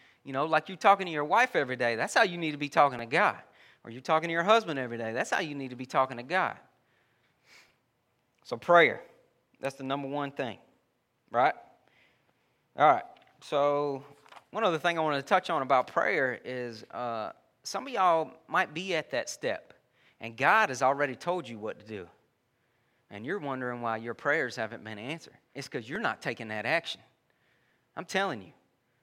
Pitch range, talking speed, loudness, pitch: 120-155 Hz, 195 wpm, -29 LUFS, 135 Hz